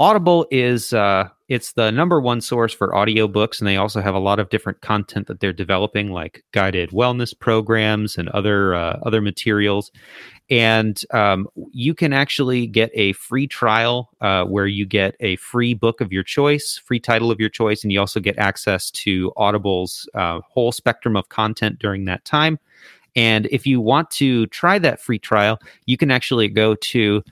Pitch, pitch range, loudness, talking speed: 110 Hz, 100-120 Hz, -19 LUFS, 185 wpm